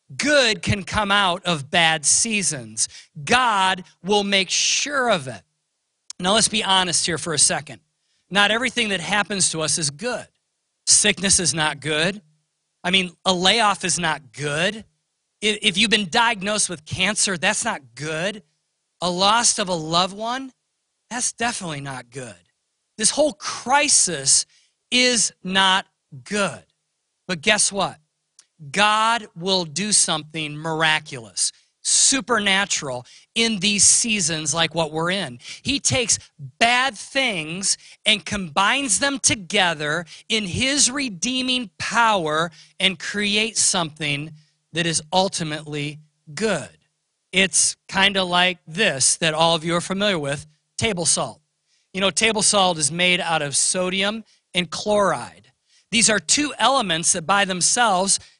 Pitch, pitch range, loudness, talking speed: 185 Hz, 160-210 Hz, -19 LUFS, 135 wpm